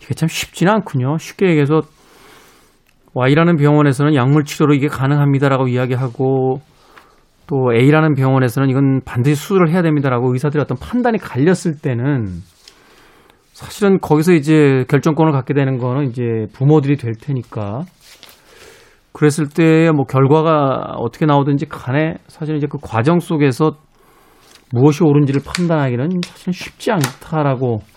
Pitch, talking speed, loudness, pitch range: 145 Hz, 335 characters per minute, -15 LUFS, 130-160 Hz